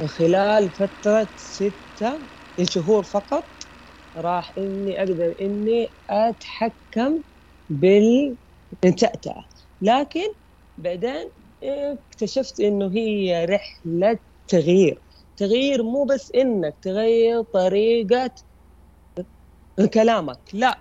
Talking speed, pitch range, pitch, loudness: 75 wpm, 185-235 Hz, 210 Hz, -21 LUFS